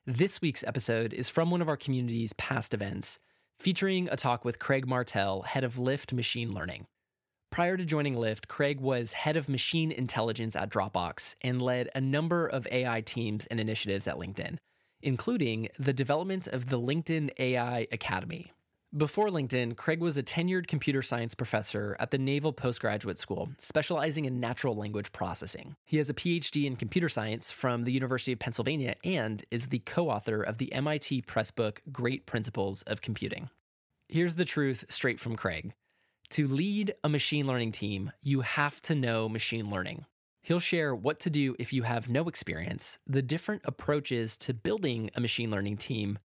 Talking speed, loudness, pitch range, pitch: 175 wpm, -31 LUFS, 115-150 Hz, 125 Hz